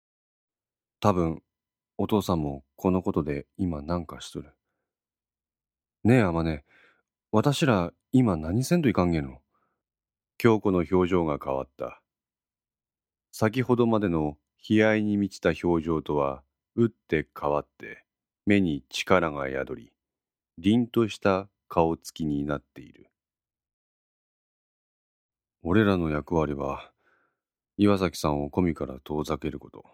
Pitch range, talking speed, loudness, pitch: 75-105 Hz, 220 characters per minute, -26 LUFS, 85 Hz